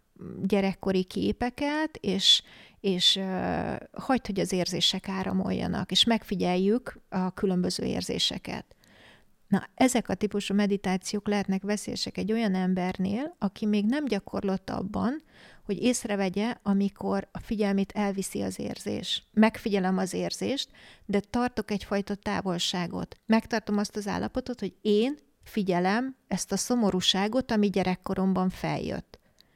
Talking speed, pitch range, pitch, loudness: 120 wpm, 190-220 Hz, 200 Hz, -28 LUFS